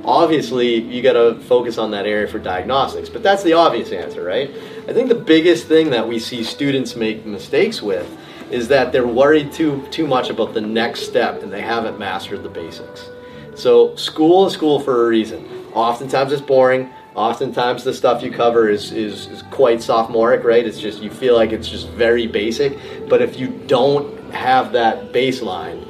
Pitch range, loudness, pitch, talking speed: 115-175 Hz, -17 LUFS, 130 Hz, 190 wpm